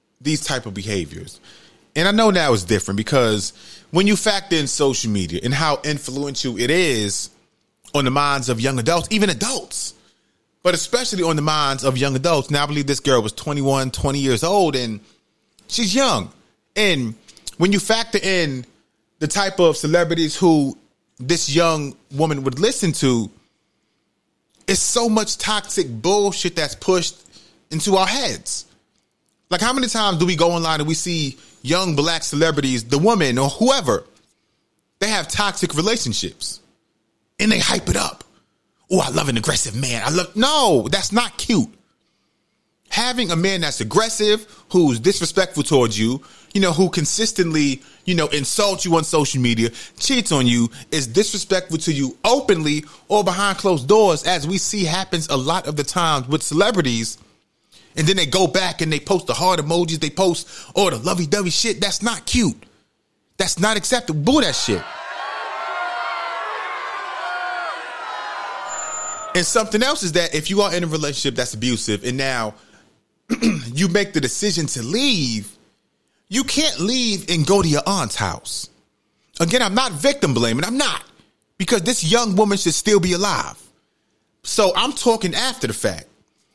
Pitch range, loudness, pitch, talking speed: 140-205 Hz, -19 LUFS, 170 Hz, 165 wpm